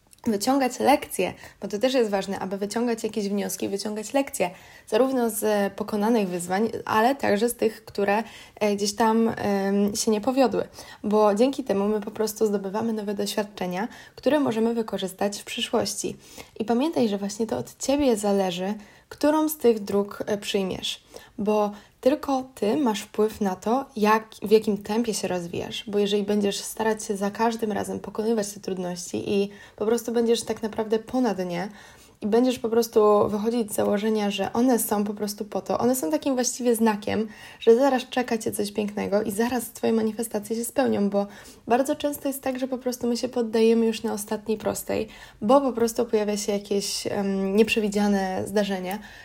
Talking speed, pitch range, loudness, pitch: 170 wpm, 205-235 Hz, -25 LUFS, 220 Hz